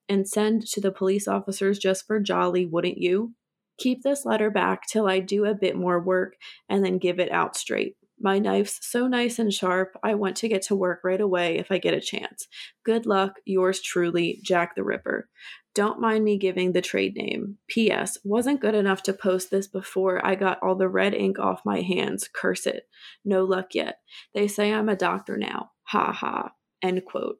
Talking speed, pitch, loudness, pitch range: 205 wpm, 195 Hz, -25 LUFS, 185-215 Hz